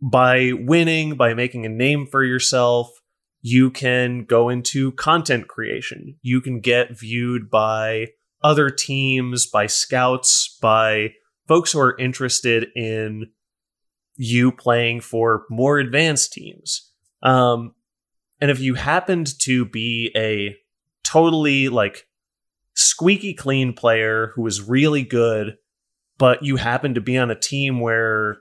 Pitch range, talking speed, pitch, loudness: 115-140 Hz, 130 wpm, 125 Hz, -18 LUFS